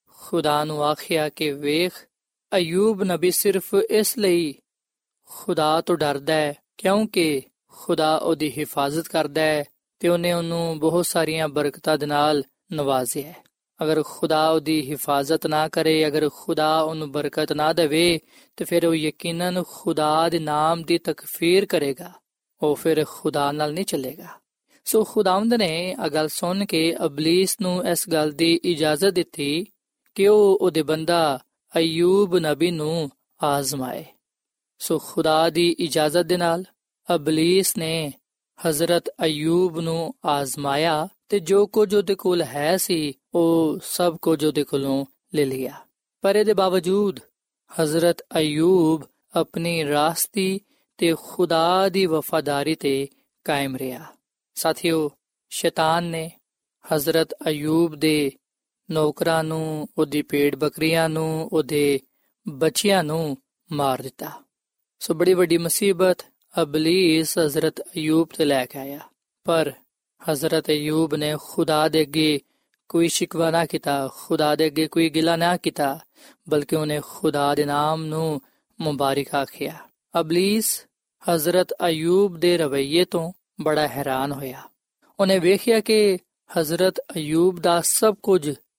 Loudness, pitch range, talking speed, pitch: -22 LUFS, 150-175 Hz, 130 wpm, 160 Hz